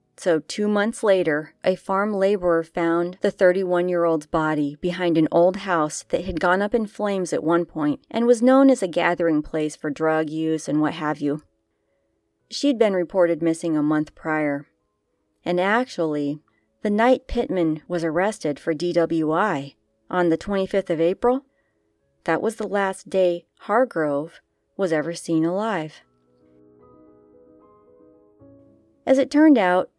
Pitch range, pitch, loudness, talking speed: 150-190 Hz, 170 Hz, -22 LUFS, 150 wpm